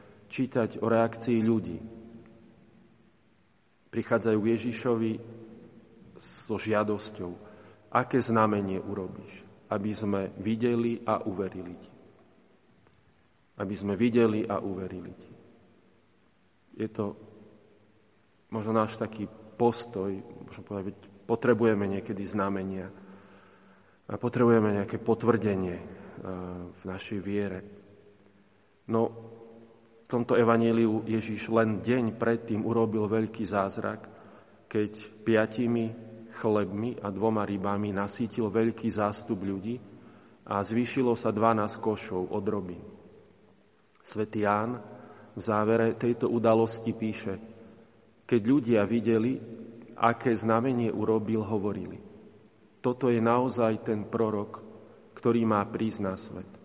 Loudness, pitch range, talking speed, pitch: -29 LUFS, 100-115 Hz, 100 wpm, 110 Hz